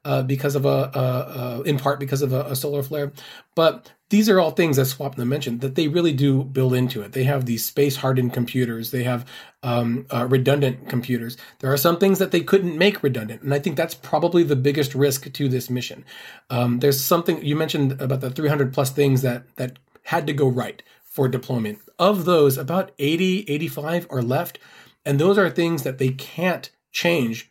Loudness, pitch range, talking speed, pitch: -22 LUFS, 130-160 Hz, 205 wpm, 140 Hz